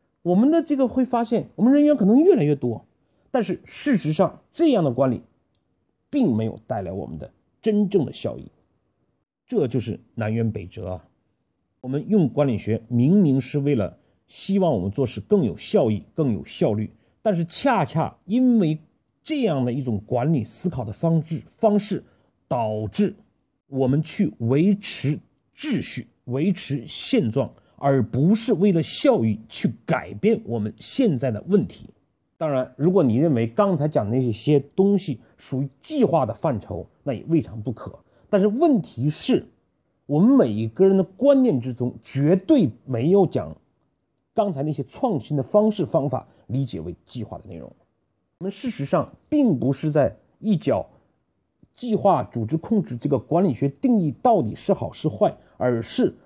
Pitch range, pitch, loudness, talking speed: 120-200 Hz, 150 Hz, -22 LUFS, 240 characters per minute